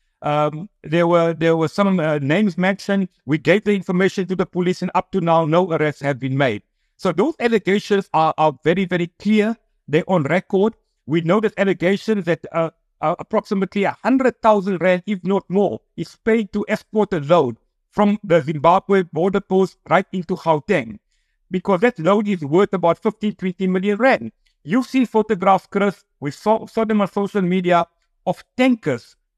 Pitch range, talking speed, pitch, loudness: 170-205 Hz, 175 wpm, 190 Hz, -19 LUFS